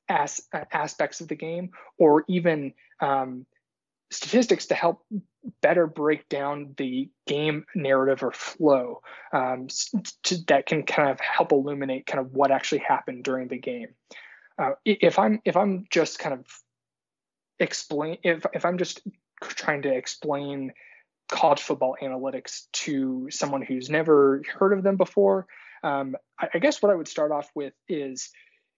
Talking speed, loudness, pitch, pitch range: 150 wpm, -25 LUFS, 155 Hz, 140-195 Hz